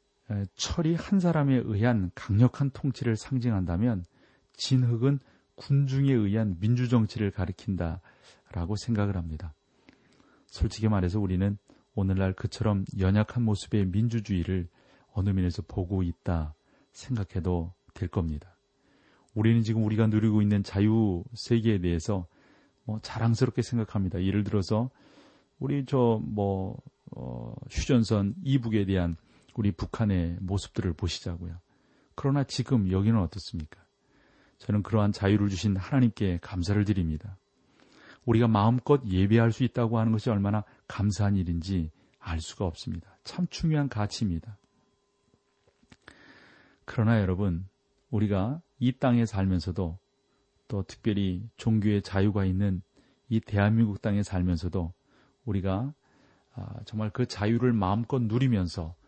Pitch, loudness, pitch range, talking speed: 105 Hz, -28 LUFS, 95-115 Hz, 285 characters per minute